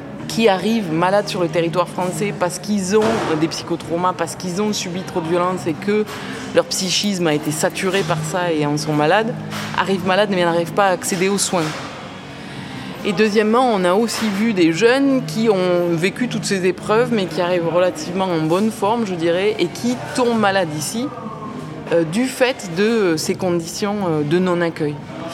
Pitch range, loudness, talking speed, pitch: 170-210 Hz, -18 LUFS, 180 wpm, 185 Hz